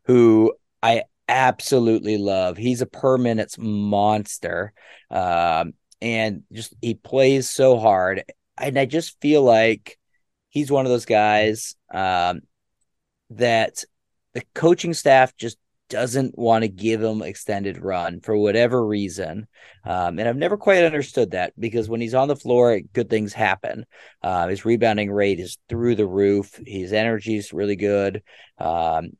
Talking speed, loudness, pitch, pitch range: 150 wpm, -21 LUFS, 115 Hz, 105-125 Hz